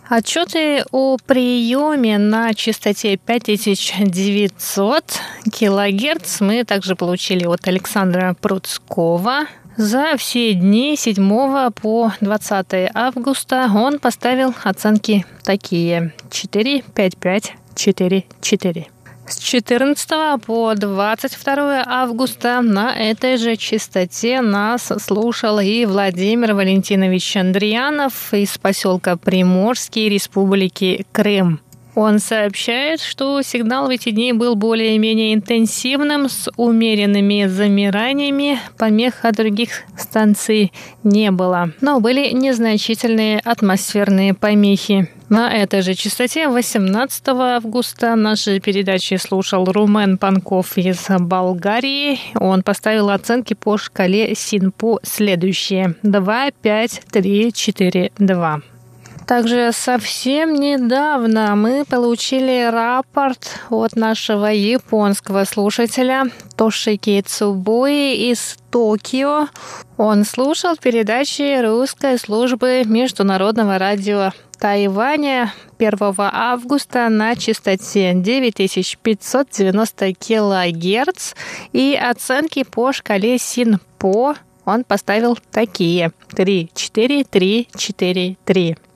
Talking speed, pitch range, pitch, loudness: 95 wpm, 195-245 Hz, 215 Hz, -16 LUFS